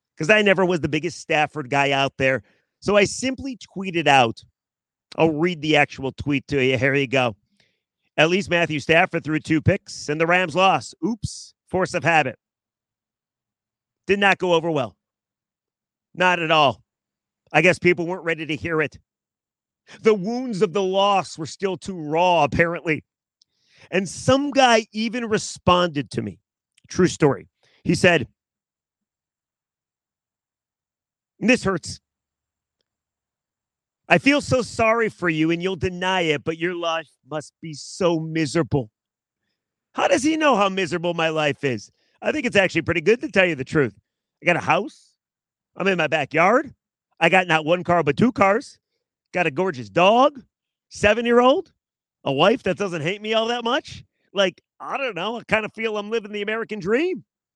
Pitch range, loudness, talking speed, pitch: 145-200 Hz, -21 LUFS, 170 wpm, 170 Hz